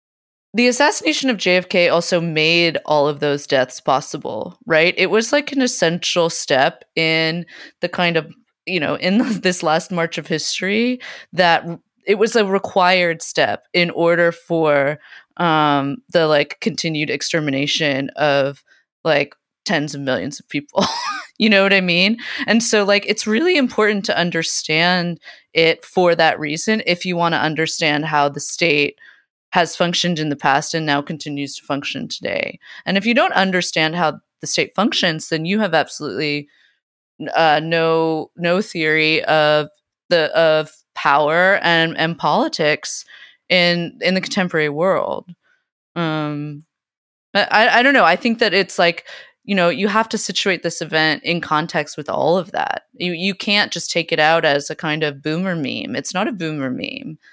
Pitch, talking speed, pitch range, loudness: 170 Hz, 165 wpm, 155-190 Hz, -17 LUFS